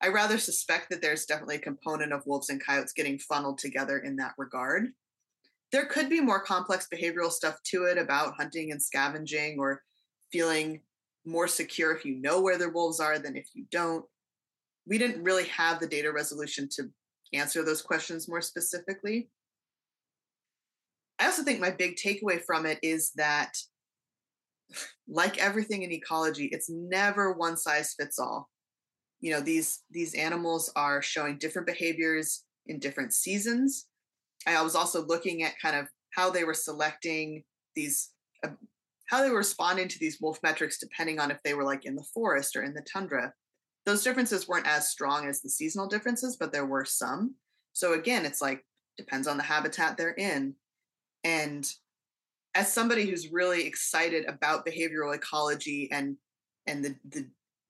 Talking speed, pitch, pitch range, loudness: 165 wpm, 165 Hz, 150-185 Hz, -30 LUFS